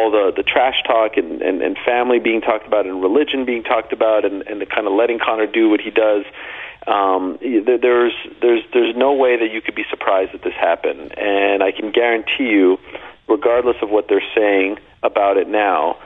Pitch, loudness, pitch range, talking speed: 115 Hz, -17 LUFS, 105-140 Hz, 200 wpm